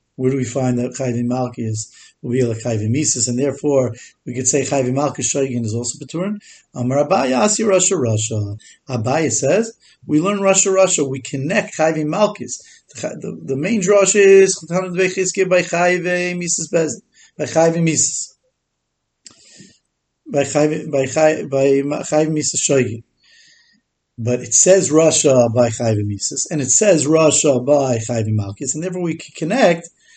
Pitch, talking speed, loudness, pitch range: 150 Hz, 135 wpm, -17 LUFS, 125-180 Hz